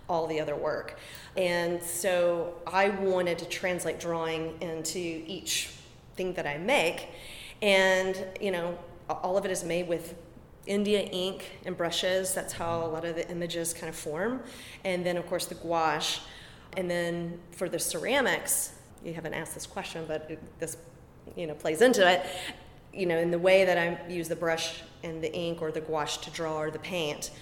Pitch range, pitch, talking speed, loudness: 165-185 Hz, 170 Hz, 185 wpm, -30 LUFS